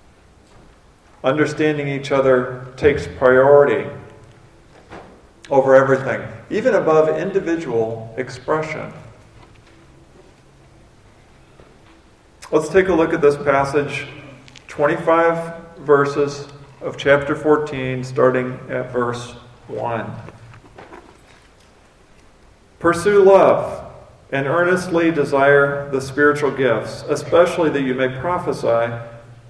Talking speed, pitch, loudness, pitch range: 80 wpm, 140 Hz, -17 LUFS, 120-150 Hz